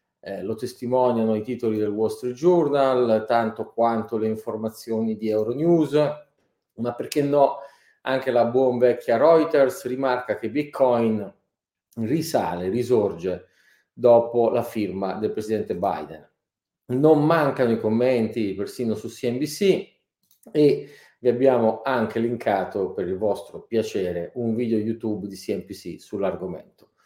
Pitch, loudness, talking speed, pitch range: 120 Hz, -23 LUFS, 125 wpm, 110-135 Hz